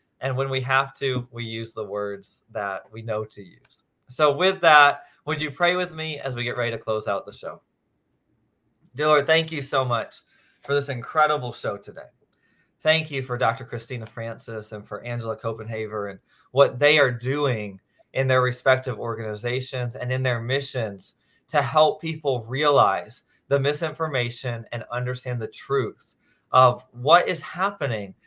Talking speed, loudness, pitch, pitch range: 165 wpm, -23 LUFS, 130 Hz, 115-145 Hz